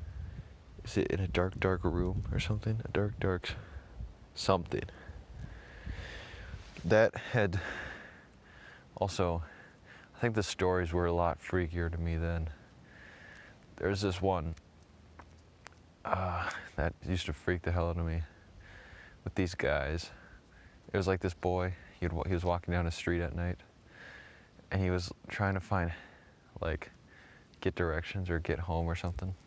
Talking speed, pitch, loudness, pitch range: 140 wpm, 90 Hz, -34 LUFS, 85-95 Hz